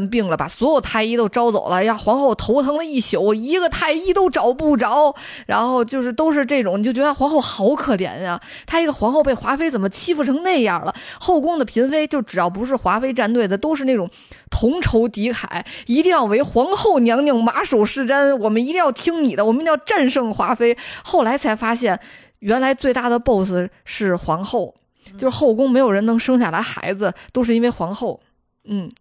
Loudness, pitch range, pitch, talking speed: -18 LUFS, 225-285 Hz, 250 Hz, 315 characters per minute